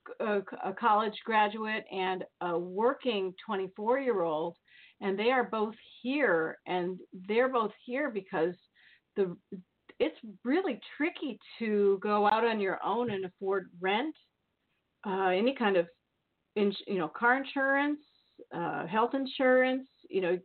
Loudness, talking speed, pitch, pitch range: -31 LUFS, 130 wpm, 215 Hz, 190-250 Hz